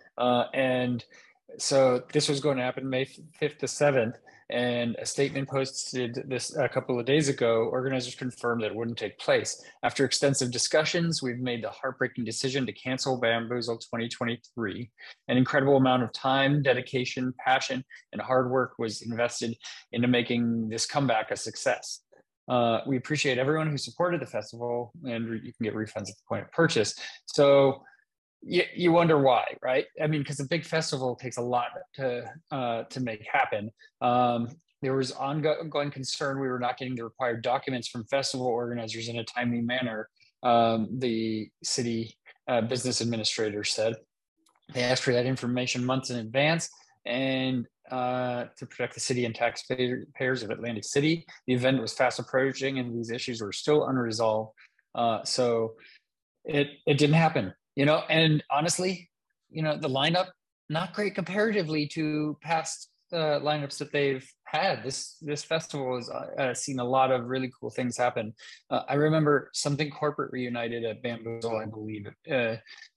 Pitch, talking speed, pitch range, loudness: 130 Hz, 165 wpm, 120-145 Hz, -28 LUFS